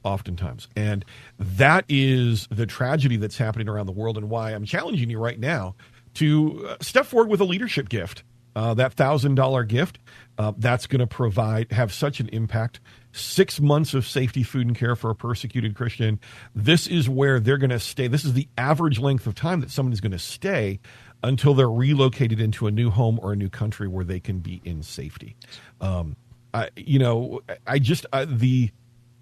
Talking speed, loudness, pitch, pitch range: 195 wpm, -23 LUFS, 120 Hz, 110-135 Hz